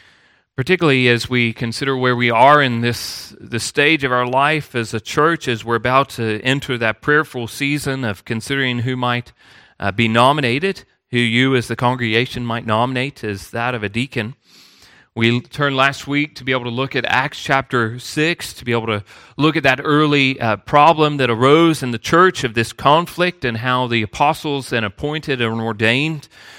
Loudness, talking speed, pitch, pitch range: -17 LUFS, 185 wpm, 125 Hz, 115-140 Hz